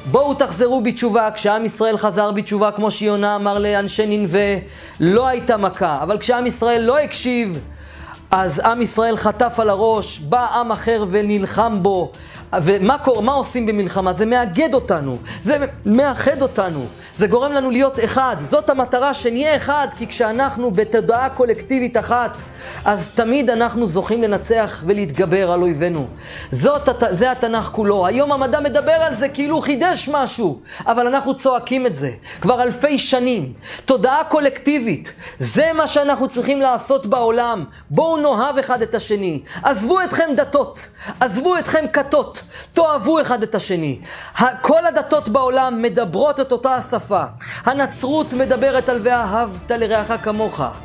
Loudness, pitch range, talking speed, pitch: -17 LUFS, 210-270 Hz, 140 wpm, 240 Hz